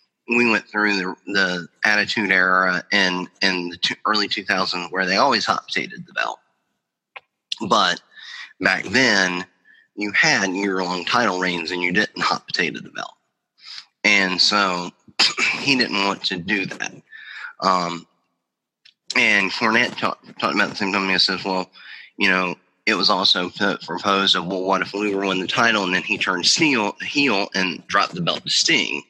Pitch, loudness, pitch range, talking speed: 95 Hz, -19 LUFS, 90-100 Hz, 170 wpm